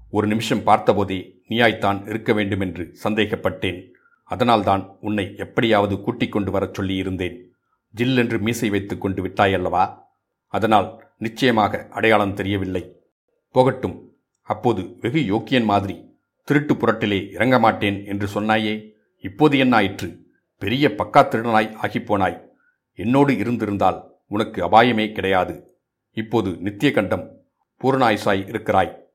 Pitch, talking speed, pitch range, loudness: 105 Hz, 100 wpm, 95-115 Hz, -20 LUFS